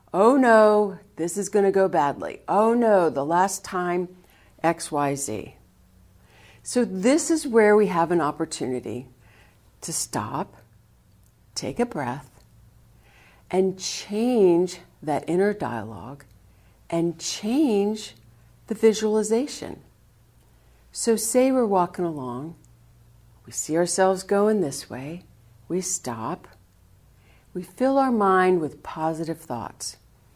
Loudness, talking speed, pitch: -23 LUFS, 110 wpm, 165 Hz